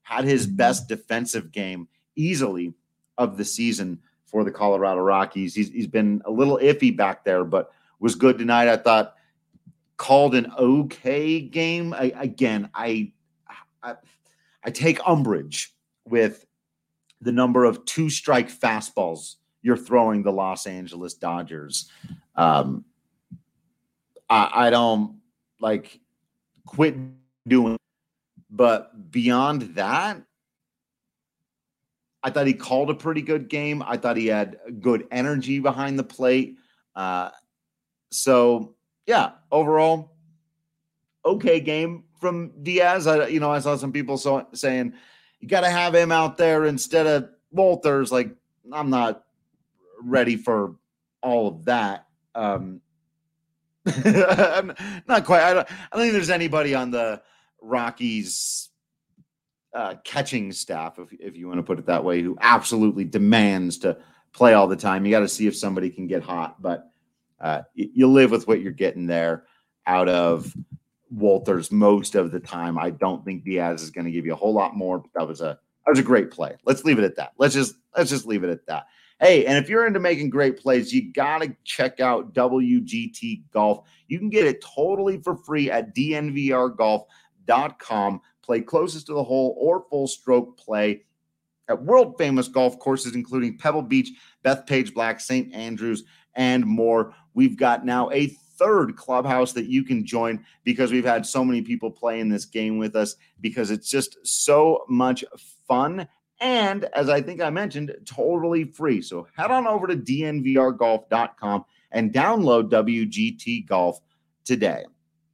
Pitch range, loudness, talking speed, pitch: 105-155 Hz, -22 LUFS, 155 wpm, 125 Hz